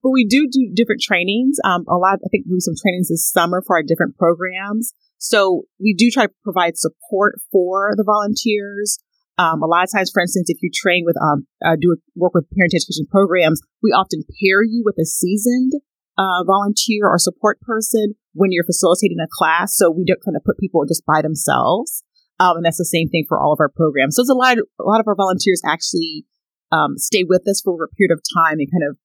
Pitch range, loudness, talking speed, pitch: 170-215 Hz, -16 LUFS, 235 wpm, 190 Hz